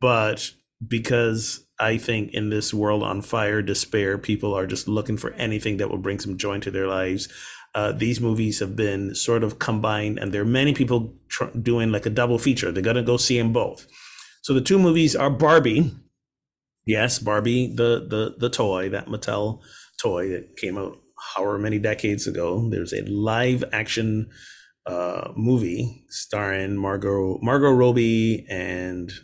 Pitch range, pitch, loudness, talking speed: 100-120 Hz, 110 Hz, -23 LUFS, 170 wpm